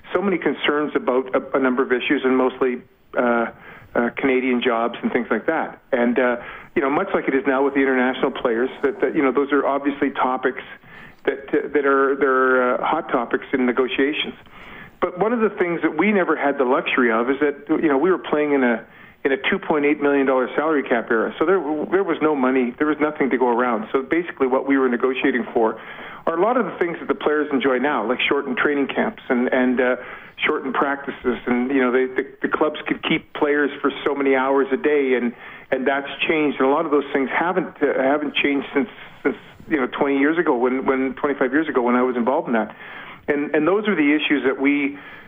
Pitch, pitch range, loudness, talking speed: 135 Hz, 130-145 Hz, -20 LUFS, 235 wpm